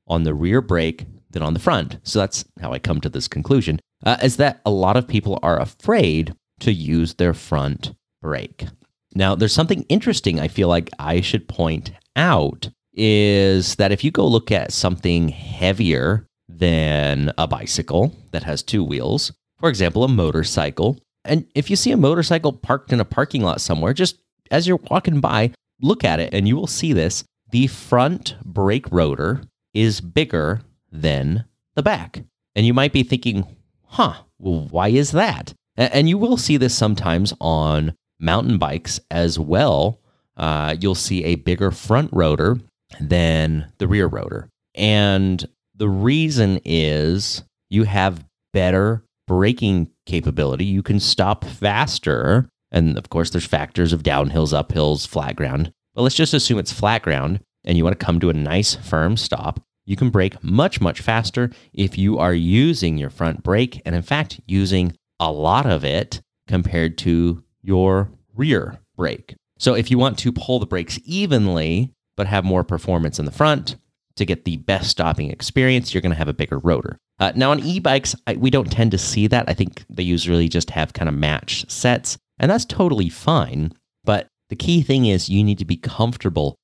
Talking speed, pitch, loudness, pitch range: 180 wpm, 100 Hz, -19 LUFS, 85-125 Hz